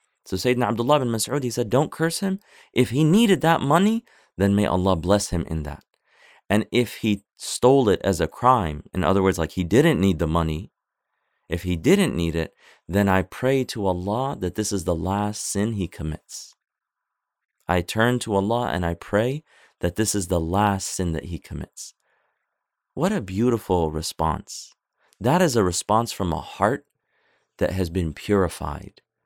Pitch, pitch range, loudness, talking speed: 100 Hz, 85-120 Hz, -23 LUFS, 180 wpm